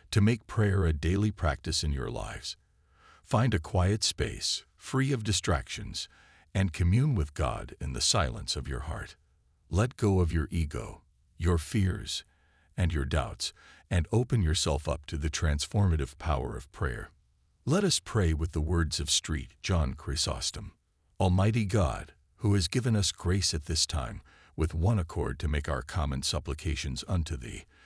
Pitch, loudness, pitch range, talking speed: 85 Hz, -30 LUFS, 80-100 Hz, 165 wpm